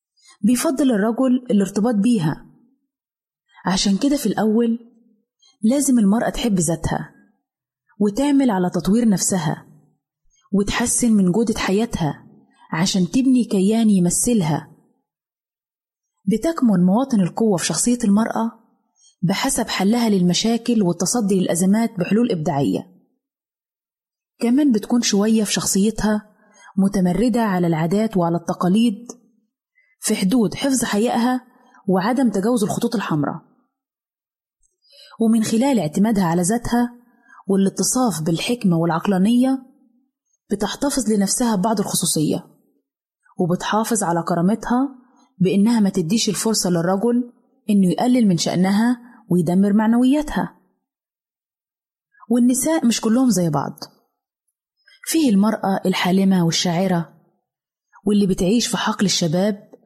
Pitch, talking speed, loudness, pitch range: 220 Hz, 95 wpm, -19 LUFS, 190-245 Hz